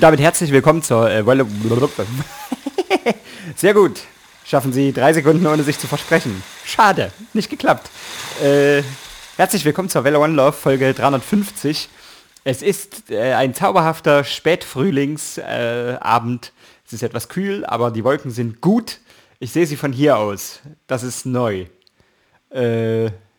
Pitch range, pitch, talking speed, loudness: 125-165 Hz, 140 Hz, 140 wpm, -17 LUFS